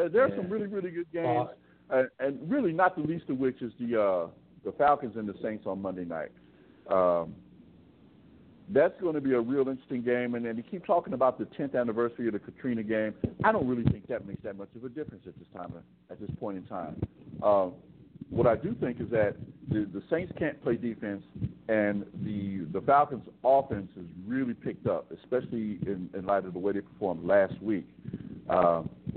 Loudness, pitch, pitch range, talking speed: -30 LUFS, 120 Hz, 100-135 Hz, 205 wpm